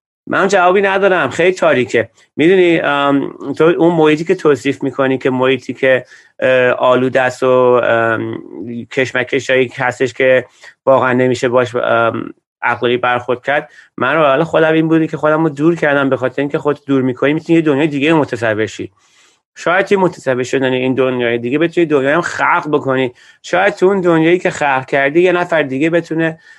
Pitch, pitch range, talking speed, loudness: 140 Hz, 130-160 Hz, 160 wpm, -13 LUFS